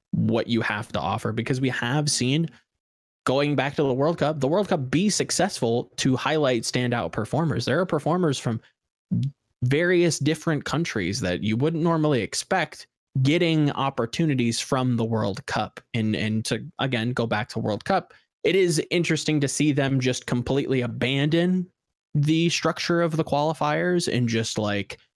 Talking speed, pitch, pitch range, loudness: 160 wpm, 135 Hz, 120-155 Hz, -24 LUFS